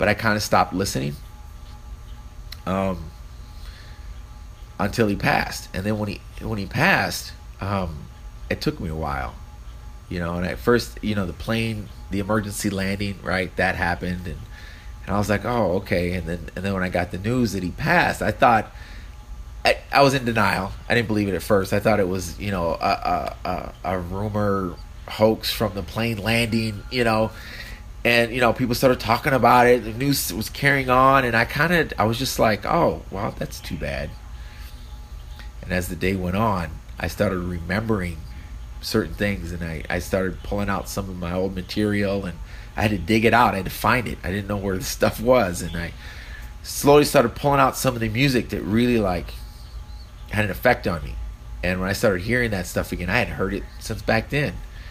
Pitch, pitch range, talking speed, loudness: 100 Hz, 85-110 Hz, 205 wpm, -22 LUFS